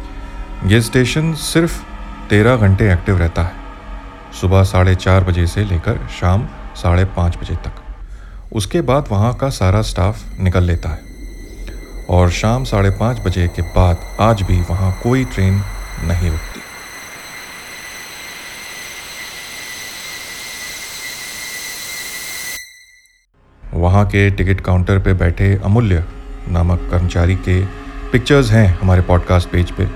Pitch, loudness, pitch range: 95 Hz, -16 LUFS, 90-115 Hz